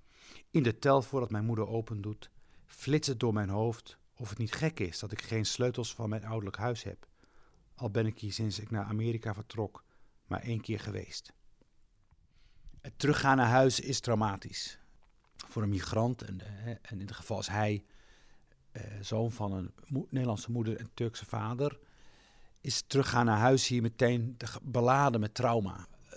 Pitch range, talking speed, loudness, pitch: 105-125 Hz, 165 wpm, -33 LUFS, 115 Hz